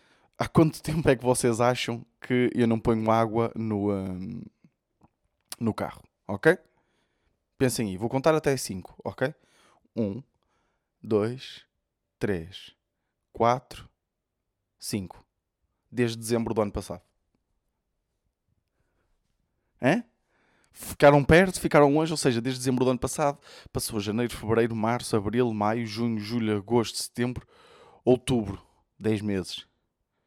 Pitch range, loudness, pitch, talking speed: 105-125 Hz, -26 LUFS, 115 Hz, 115 wpm